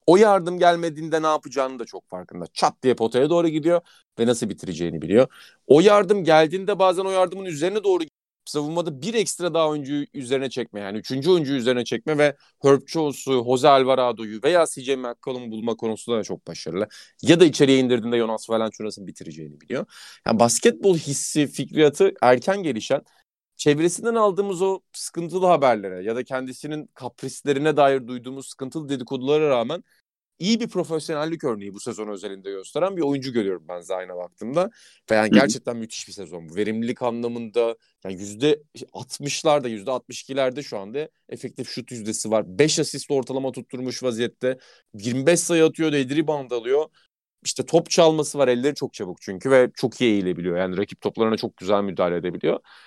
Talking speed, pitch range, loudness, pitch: 160 wpm, 115-160 Hz, -22 LUFS, 135 Hz